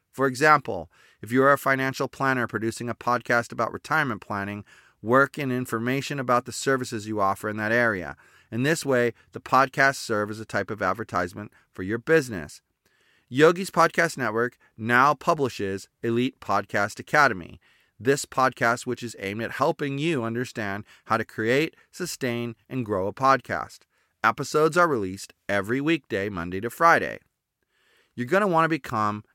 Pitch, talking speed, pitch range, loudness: 120 Hz, 160 wpm, 110-135 Hz, -24 LUFS